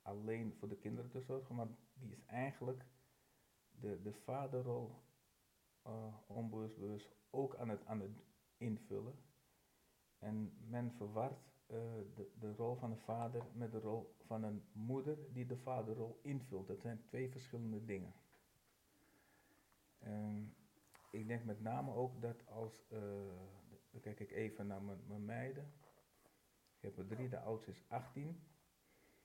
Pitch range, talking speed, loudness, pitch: 105-125 Hz, 145 wpm, -48 LUFS, 115 Hz